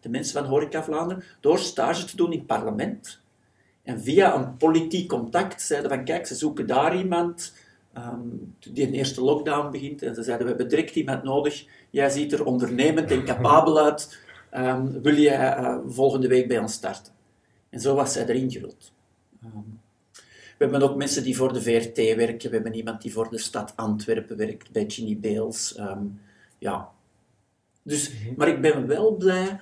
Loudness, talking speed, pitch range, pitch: -24 LUFS, 185 wpm, 115-150 Hz, 135 Hz